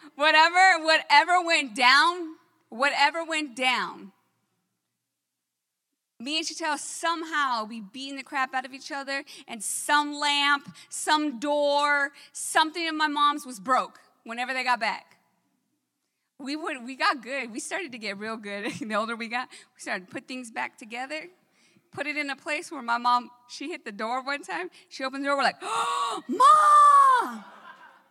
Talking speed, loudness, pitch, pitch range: 165 wpm, -24 LUFS, 285 Hz, 255-320 Hz